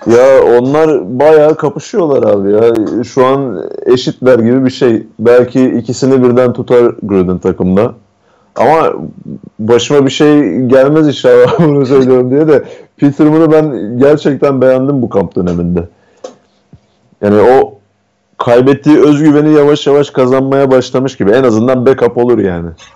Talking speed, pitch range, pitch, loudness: 130 wpm, 120-150 Hz, 130 Hz, -9 LUFS